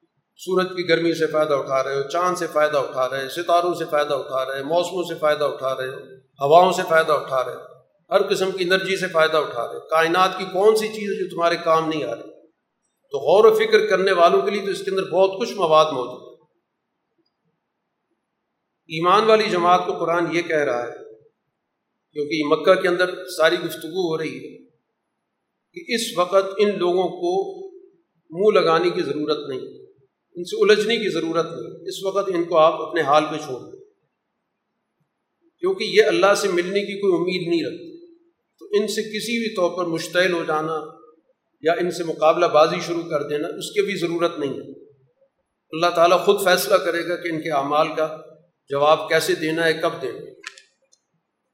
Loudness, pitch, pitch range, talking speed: -20 LUFS, 175 Hz, 160-200 Hz, 195 wpm